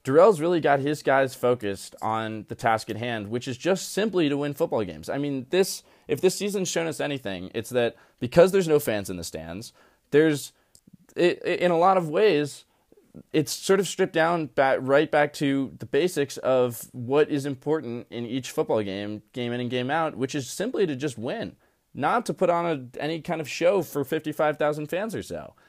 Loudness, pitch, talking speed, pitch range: -25 LUFS, 145 Hz, 205 wpm, 125-165 Hz